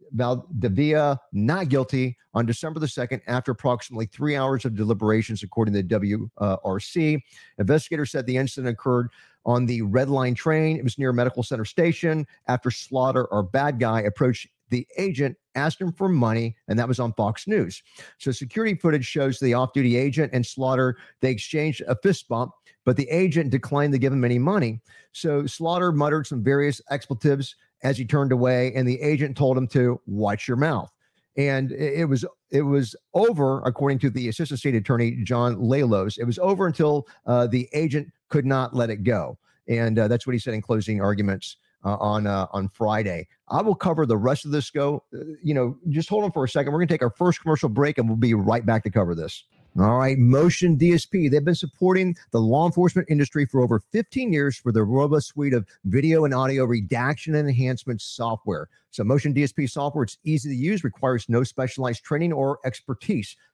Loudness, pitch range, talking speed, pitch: -23 LUFS, 120-150 Hz, 195 wpm, 130 Hz